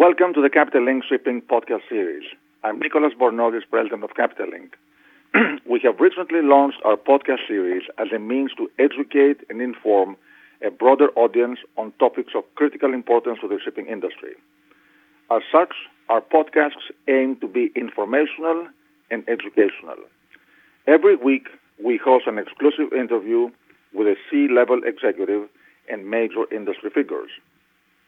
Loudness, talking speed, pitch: -20 LUFS, 140 wpm, 145 Hz